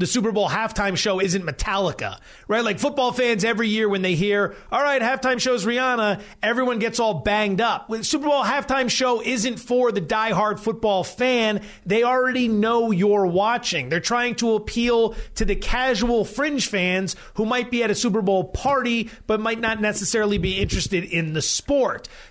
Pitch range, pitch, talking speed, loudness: 200-245 Hz, 225 Hz, 185 wpm, -21 LUFS